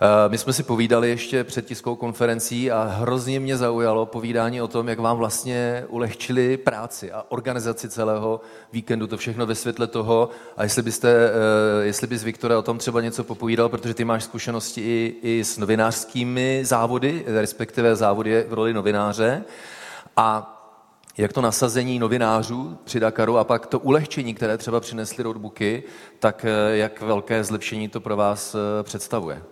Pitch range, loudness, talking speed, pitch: 110-120 Hz, -22 LUFS, 155 wpm, 115 Hz